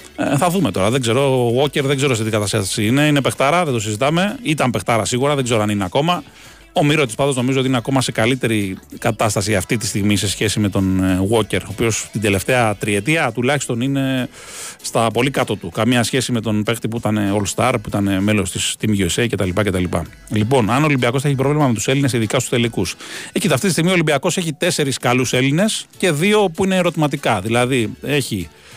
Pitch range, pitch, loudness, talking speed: 105-140 Hz, 125 Hz, -17 LUFS, 210 wpm